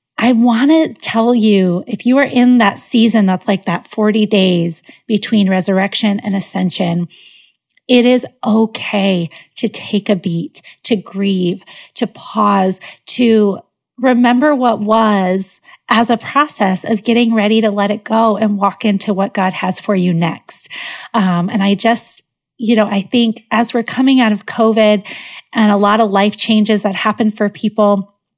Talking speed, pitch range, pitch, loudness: 165 wpm, 195-230 Hz, 210 Hz, -14 LUFS